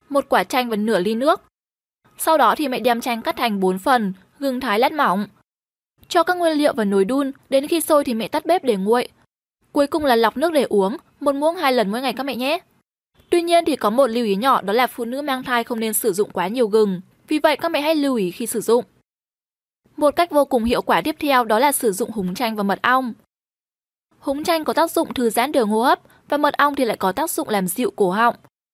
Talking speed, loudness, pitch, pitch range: 255 wpm, -19 LUFS, 255 Hz, 225-295 Hz